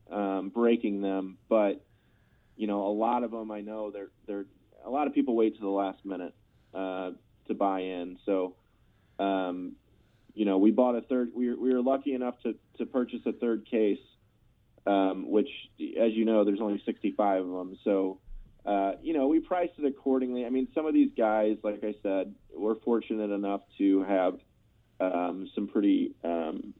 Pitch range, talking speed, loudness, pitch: 95-120 Hz, 185 wpm, -30 LUFS, 105 Hz